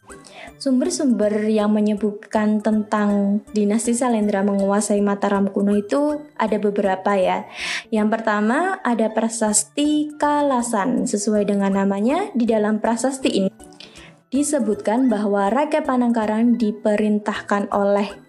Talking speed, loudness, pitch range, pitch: 100 wpm, -20 LUFS, 205-245 Hz, 215 Hz